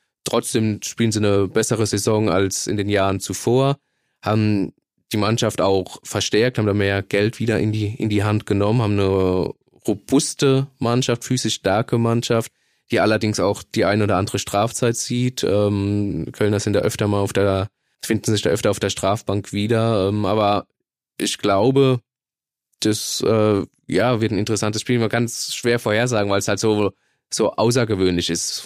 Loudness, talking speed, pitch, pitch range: -20 LUFS, 170 wpm, 105 Hz, 100-115 Hz